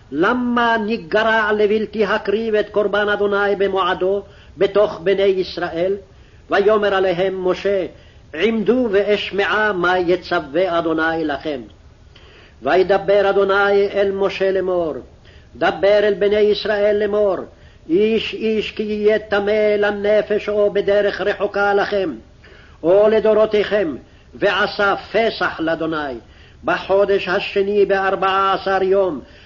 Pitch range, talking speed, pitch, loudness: 190-210 Hz, 100 wpm, 200 Hz, -17 LUFS